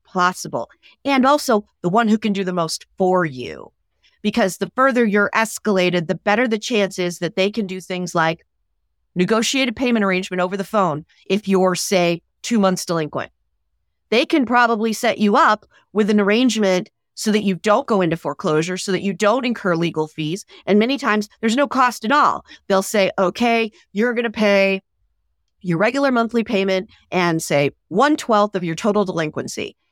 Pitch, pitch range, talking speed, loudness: 195 Hz, 175-225 Hz, 185 wpm, -19 LUFS